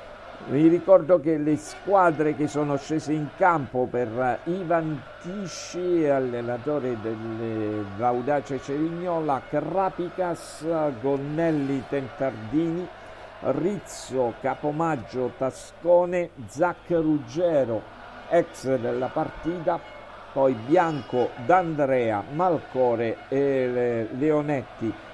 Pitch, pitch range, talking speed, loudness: 150 Hz, 130-170 Hz, 80 wpm, -25 LUFS